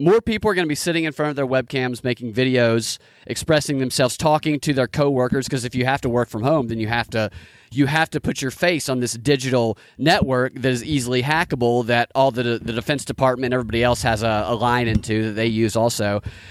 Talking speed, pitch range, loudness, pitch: 230 wpm, 115-145 Hz, -20 LUFS, 125 Hz